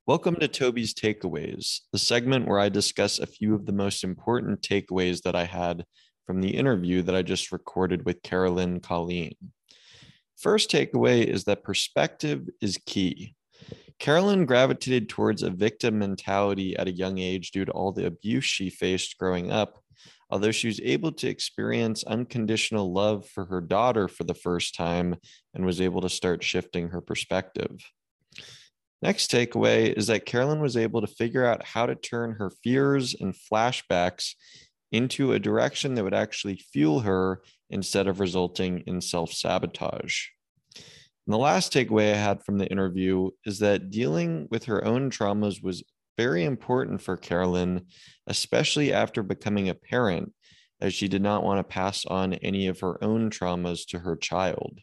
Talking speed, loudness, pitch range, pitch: 165 wpm, -26 LUFS, 90-115 Hz, 100 Hz